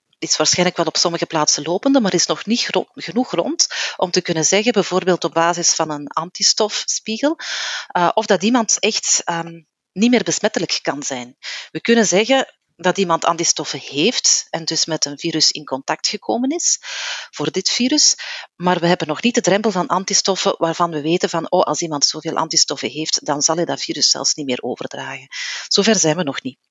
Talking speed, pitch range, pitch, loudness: 195 wpm, 160-215 Hz, 175 Hz, -17 LUFS